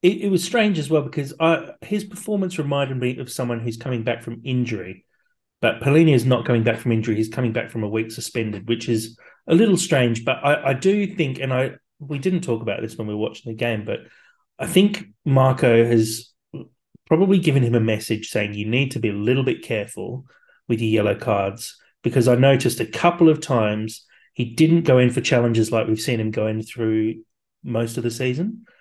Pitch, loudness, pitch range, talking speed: 125 Hz, -21 LUFS, 115-155 Hz, 215 wpm